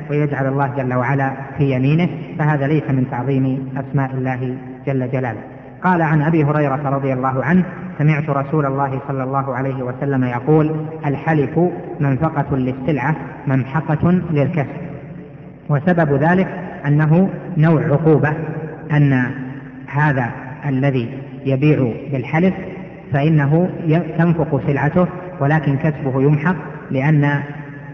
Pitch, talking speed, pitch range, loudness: 145 Hz, 110 wpm, 135-160 Hz, -18 LUFS